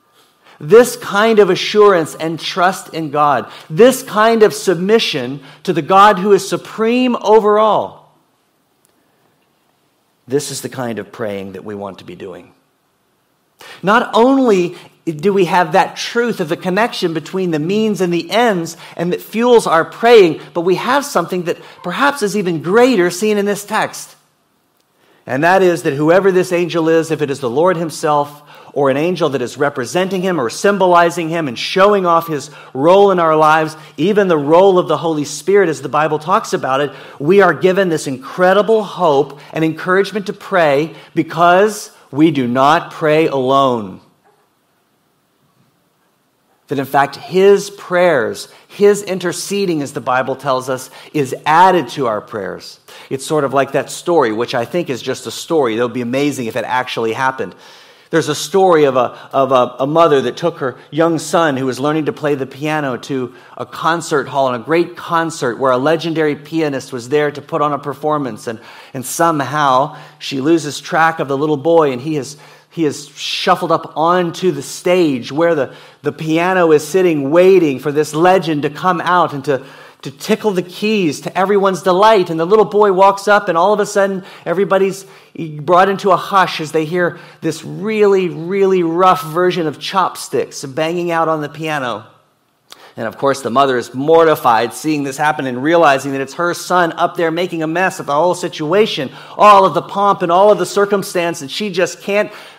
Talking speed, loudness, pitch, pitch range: 185 wpm, -14 LUFS, 165 Hz, 145-190 Hz